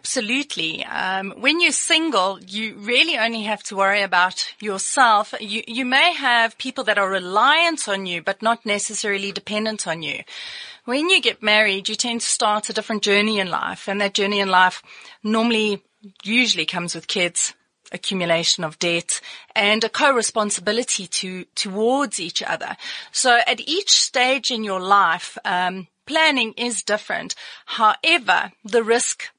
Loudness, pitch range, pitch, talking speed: -19 LUFS, 195-245 Hz, 215 Hz, 155 wpm